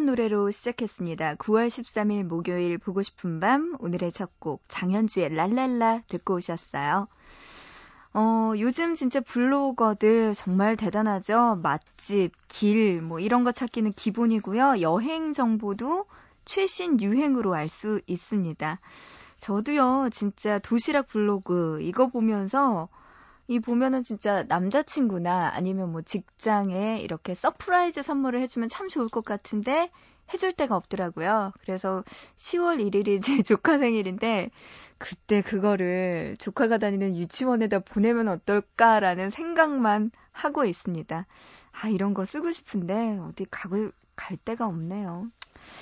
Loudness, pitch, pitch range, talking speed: -26 LUFS, 215 Hz, 190-250 Hz, 280 characters per minute